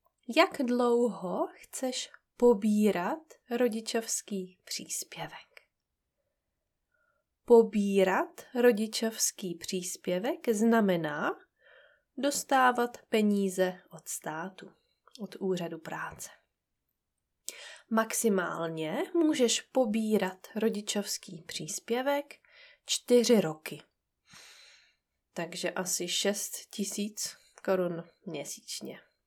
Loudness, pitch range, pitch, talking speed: -30 LUFS, 185-245 Hz, 220 Hz, 60 wpm